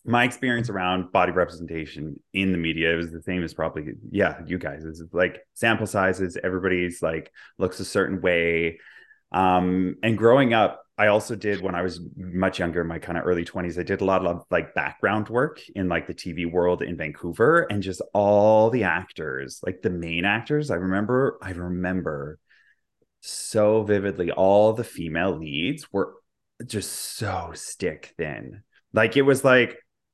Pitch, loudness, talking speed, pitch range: 95 Hz, -24 LUFS, 170 wpm, 85-105 Hz